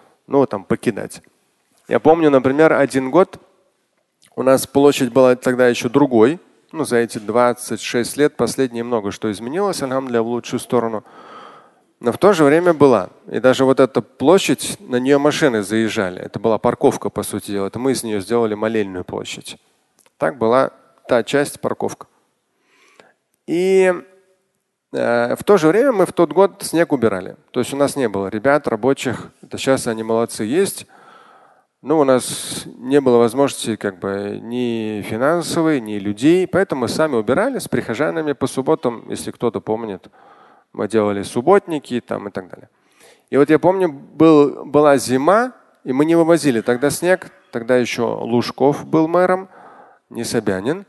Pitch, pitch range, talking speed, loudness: 130 Hz, 115-150 Hz, 160 wpm, -17 LUFS